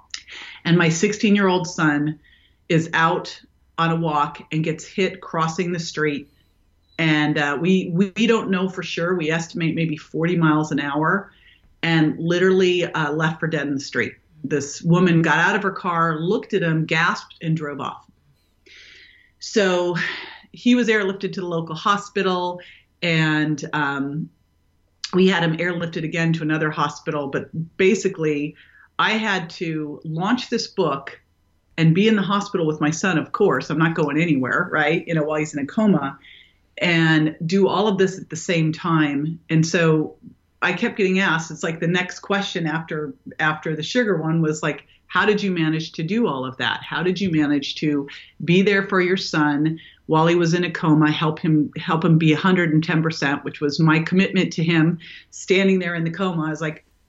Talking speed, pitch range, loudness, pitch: 180 wpm, 155-185 Hz, -20 LUFS, 165 Hz